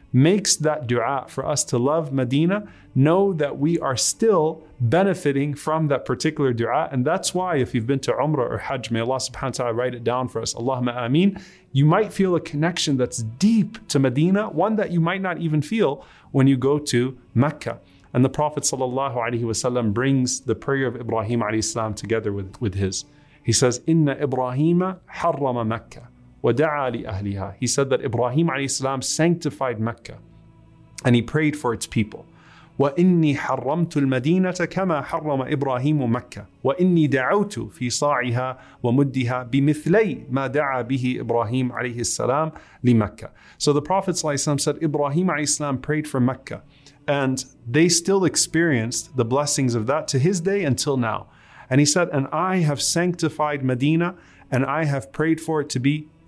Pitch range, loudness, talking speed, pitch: 125-160 Hz, -22 LUFS, 180 wpm, 140 Hz